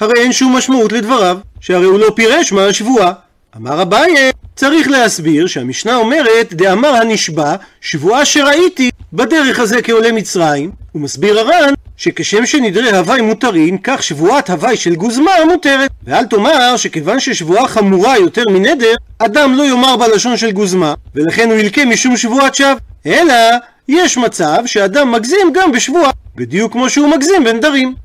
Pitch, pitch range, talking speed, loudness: 230 Hz, 195-270 Hz, 145 wpm, -10 LUFS